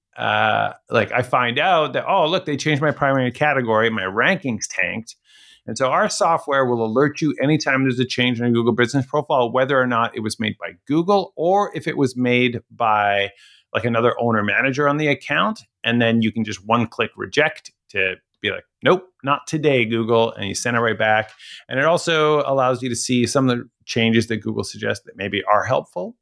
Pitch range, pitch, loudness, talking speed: 115-150 Hz, 125 Hz, -19 LUFS, 210 wpm